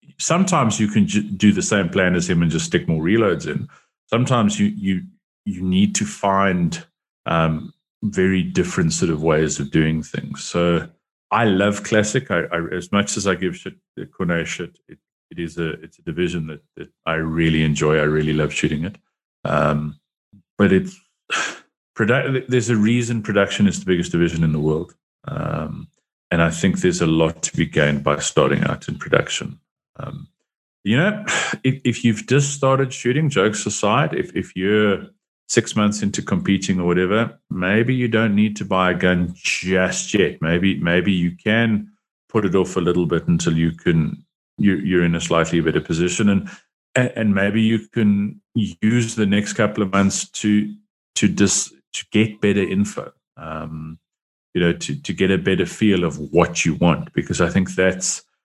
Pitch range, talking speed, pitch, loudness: 85-115 Hz, 185 wpm, 100 Hz, -19 LUFS